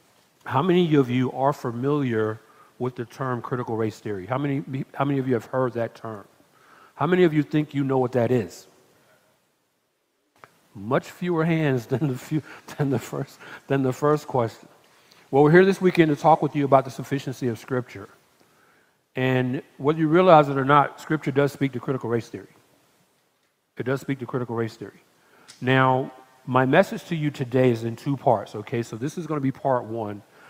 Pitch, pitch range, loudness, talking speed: 135 Hz, 125-145 Hz, -23 LUFS, 195 wpm